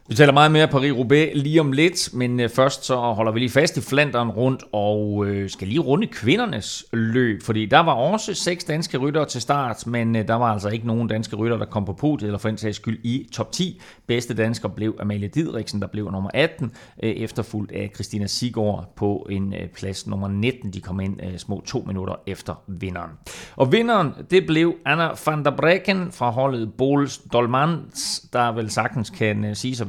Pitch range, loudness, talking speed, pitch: 105-140 Hz, -22 LUFS, 195 wpm, 120 Hz